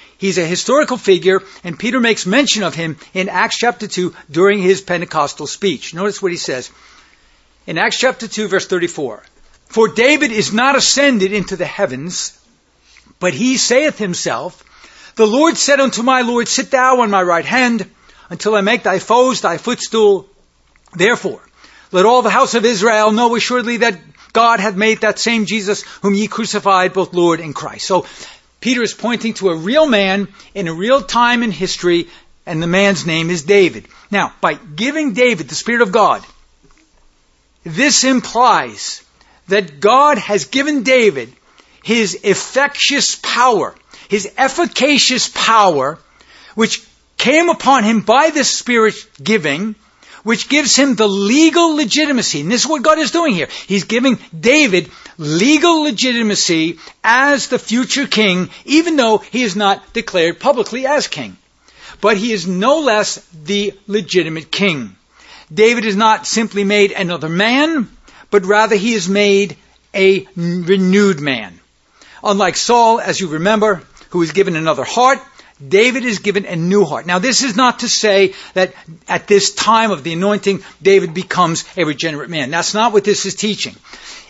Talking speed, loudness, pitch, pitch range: 160 wpm, -14 LUFS, 210 Hz, 190-245 Hz